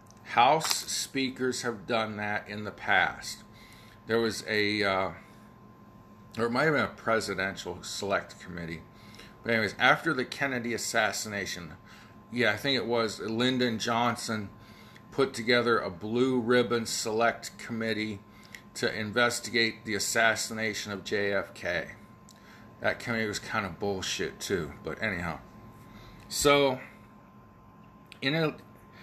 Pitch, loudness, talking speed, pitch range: 110 Hz, -29 LUFS, 120 wpm, 105-120 Hz